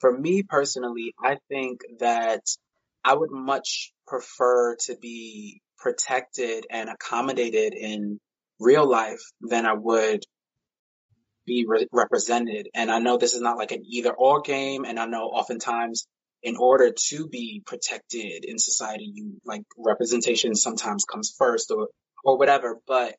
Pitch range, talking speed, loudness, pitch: 115-140 Hz, 145 wpm, -24 LUFS, 120 Hz